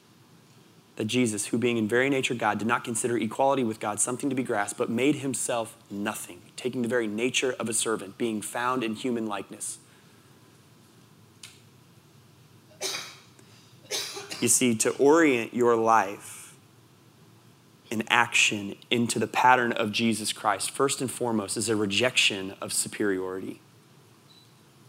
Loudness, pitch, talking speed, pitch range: -26 LUFS, 120 Hz, 135 wpm, 110-125 Hz